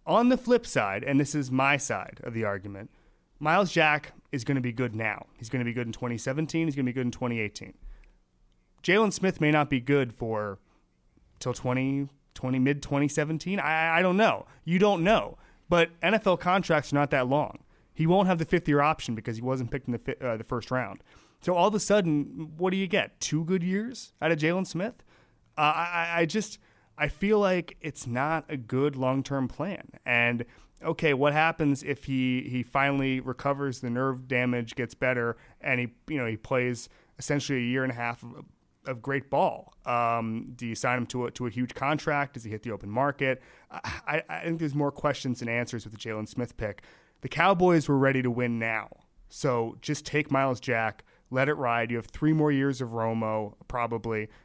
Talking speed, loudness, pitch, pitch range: 215 wpm, -28 LUFS, 135 Hz, 120-155 Hz